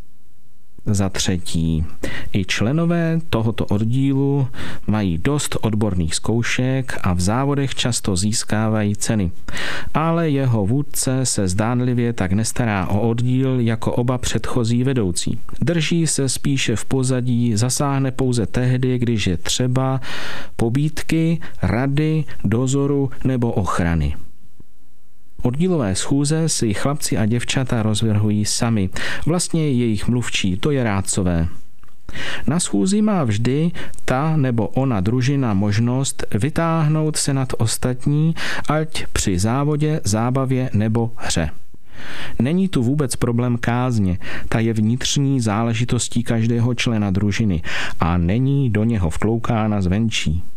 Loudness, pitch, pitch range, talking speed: -20 LUFS, 120 Hz, 105-135 Hz, 115 wpm